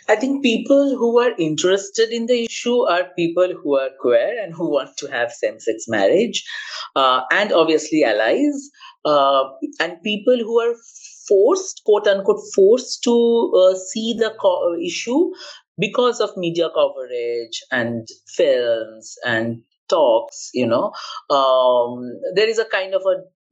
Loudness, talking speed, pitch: -18 LUFS, 150 wpm, 230 Hz